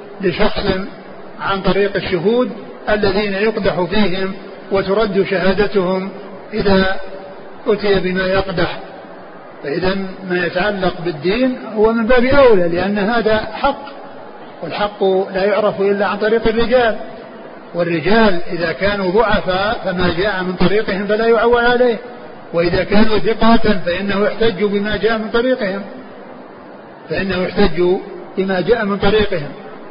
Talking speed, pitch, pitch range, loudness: 115 wpm, 200 Hz, 190-220 Hz, -16 LUFS